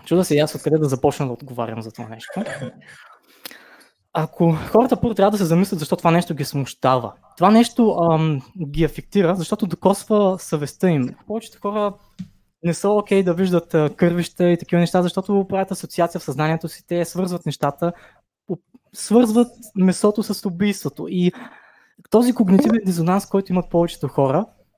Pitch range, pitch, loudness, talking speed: 160-200 Hz, 180 Hz, -20 LUFS, 155 wpm